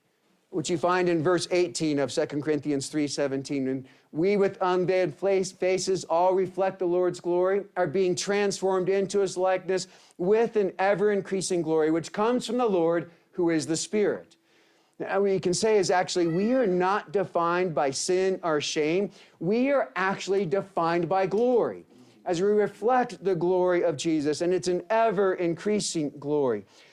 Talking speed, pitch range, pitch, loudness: 165 wpm, 170-195 Hz, 185 Hz, -26 LUFS